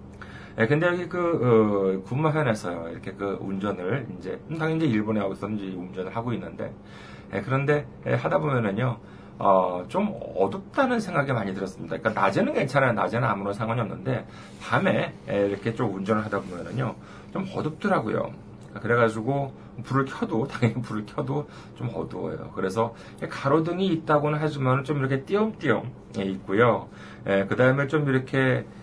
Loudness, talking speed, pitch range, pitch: -26 LUFS, 355 characters per minute, 100-145 Hz, 115 Hz